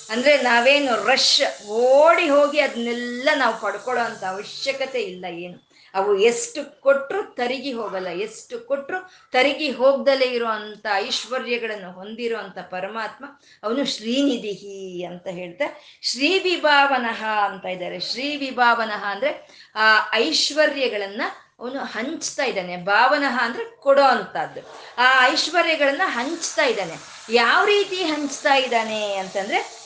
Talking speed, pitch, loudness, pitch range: 105 wpm, 255 Hz, -20 LUFS, 215-290 Hz